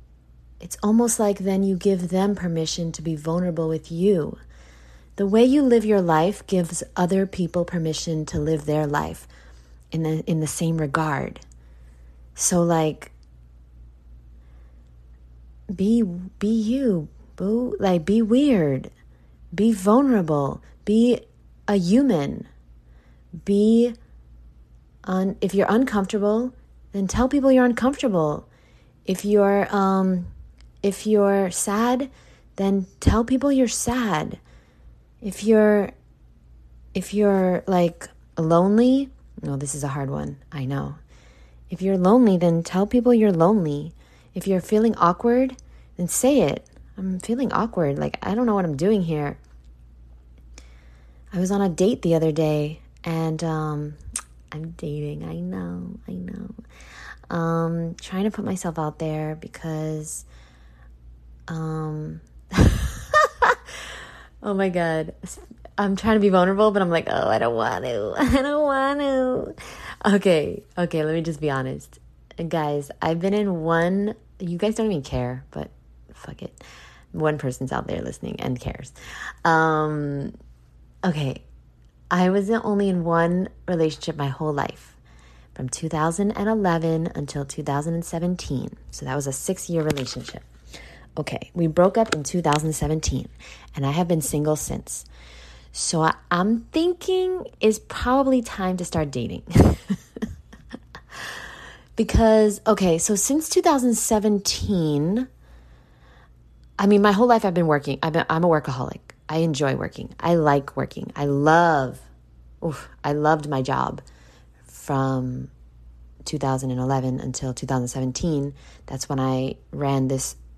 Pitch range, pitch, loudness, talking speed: 125-200 Hz, 165 Hz, -22 LUFS, 130 wpm